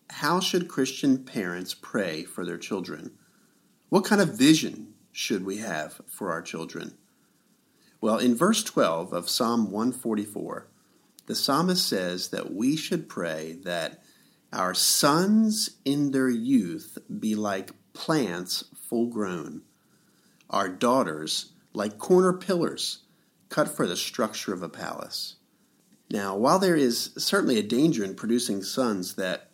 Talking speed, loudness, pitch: 135 wpm, -26 LUFS, 140 Hz